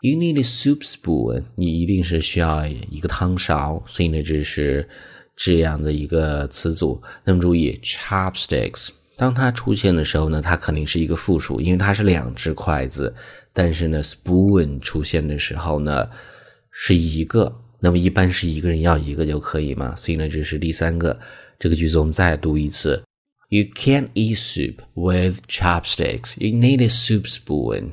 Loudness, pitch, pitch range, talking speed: -20 LUFS, 85 Hz, 75-95 Hz, 370 characters per minute